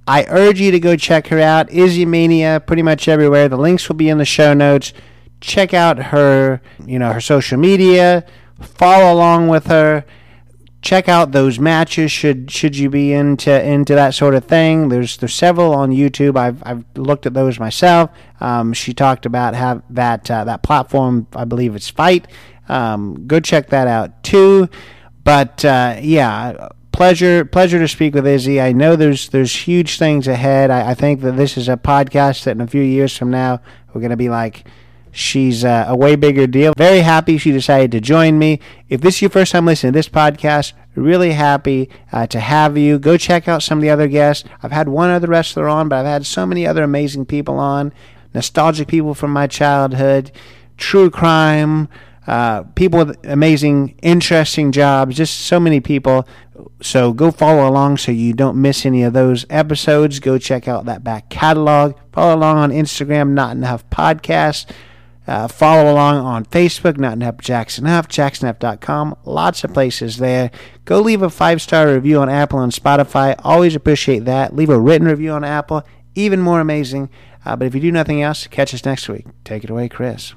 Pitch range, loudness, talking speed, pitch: 125-155 Hz, -13 LUFS, 195 wpm, 140 Hz